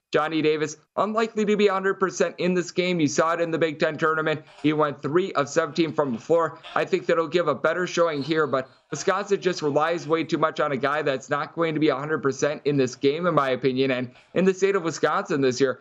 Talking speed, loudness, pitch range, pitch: 240 wpm, -24 LUFS, 145-175 Hz, 155 Hz